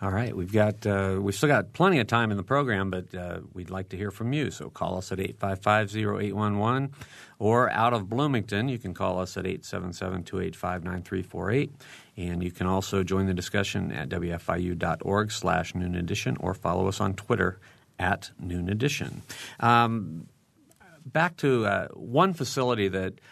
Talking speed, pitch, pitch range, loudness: 165 wpm, 100 Hz, 90-120 Hz, -28 LUFS